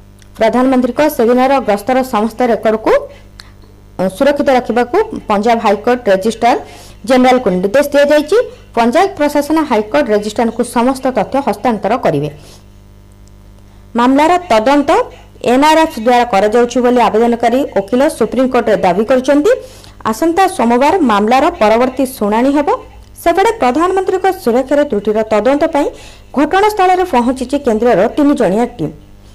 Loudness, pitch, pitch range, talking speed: -12 LUFS, 245 Hz, 210-290 Hz, 100 wpm